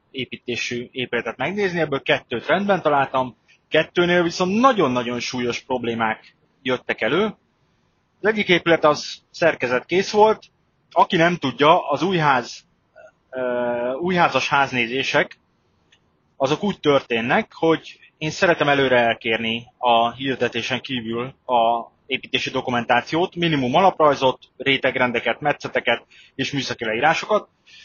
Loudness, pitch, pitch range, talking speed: -20 LUFS, 130 Hz, 120-160 Hz, 105 wpm